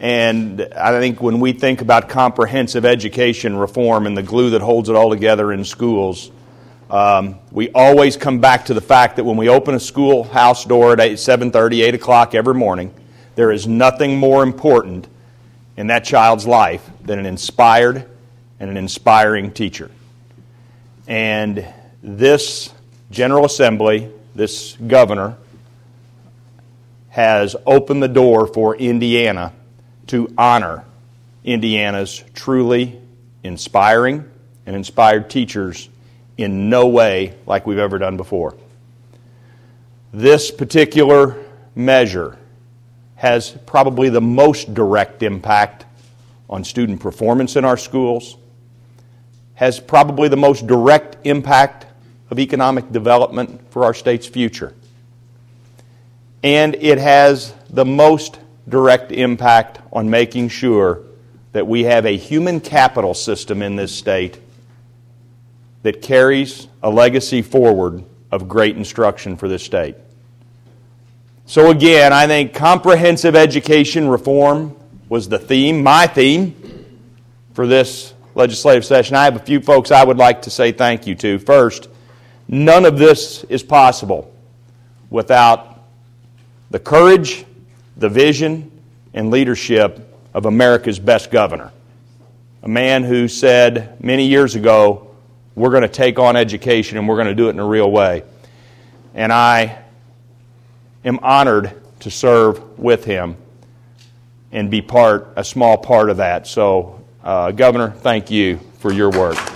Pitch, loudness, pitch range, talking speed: 120 Hz, -13 LUFS, 115-130 Hz, 130 wpm